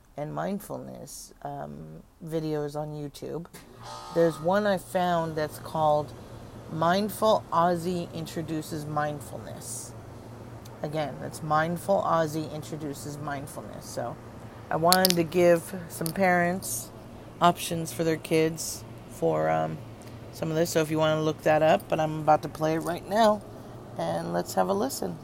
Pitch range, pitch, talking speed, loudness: 115-165 Hz, 155 Hz, 140 wpm, -27 LUFS